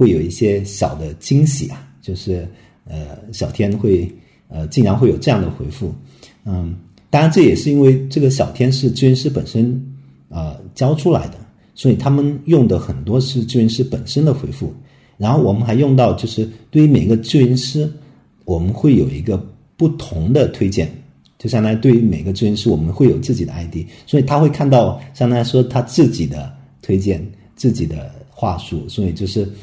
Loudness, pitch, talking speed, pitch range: -16 LUFS, 115 Hz, 275 characters per minute, 95-135 Hz